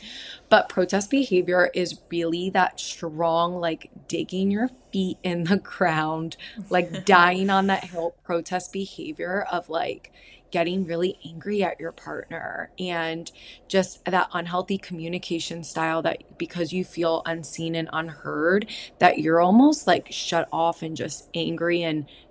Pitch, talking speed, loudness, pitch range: 175 Hz, 140 wpm, -24 LUFS, 165-185 Hz